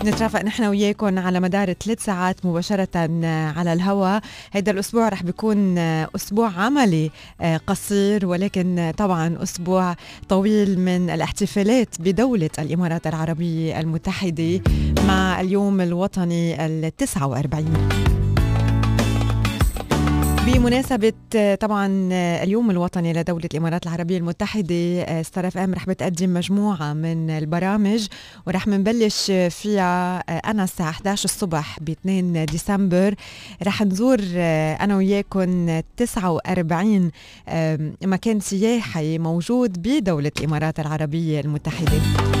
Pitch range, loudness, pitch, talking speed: 160-200 Hz, -21 LUFS, 180 Hz, 95 wpm